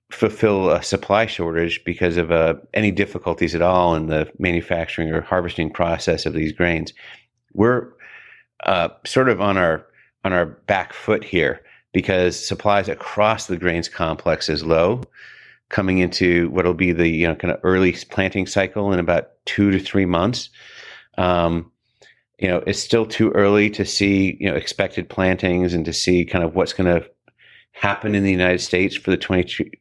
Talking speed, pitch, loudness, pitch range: 175 wpm, 90 Hz, -20 LUFS, 85-100 Hz